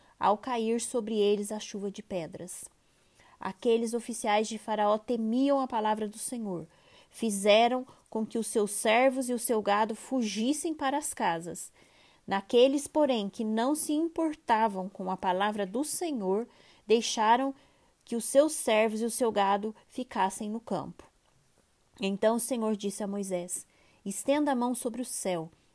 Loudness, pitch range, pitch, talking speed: -29 LUFS, 205-255 Hz, 225 Hz, 155 wpm